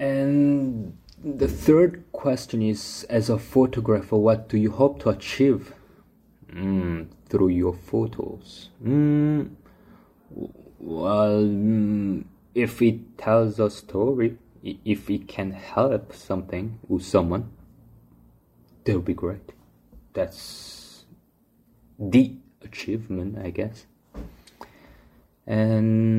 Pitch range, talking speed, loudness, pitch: 95-125 Hz, 100 wpm, -24 LUFS, 110 Hz